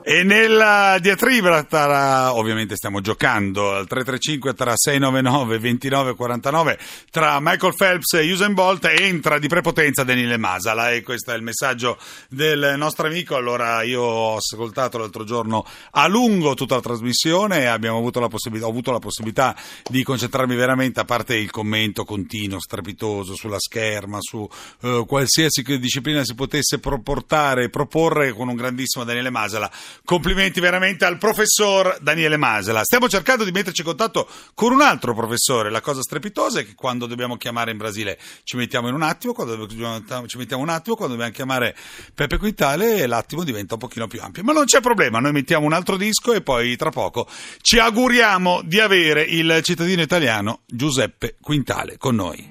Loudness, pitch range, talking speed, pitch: -19 LUFS, 115-170 Hz, 160 wpm, 135 Hz